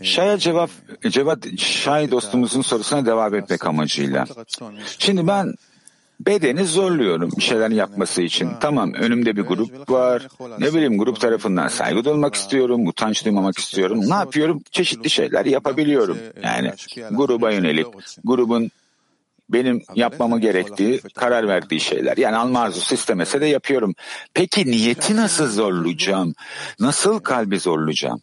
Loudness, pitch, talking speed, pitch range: -19 LUFS, 125 Hz, 130 wpm, 110-155 Hz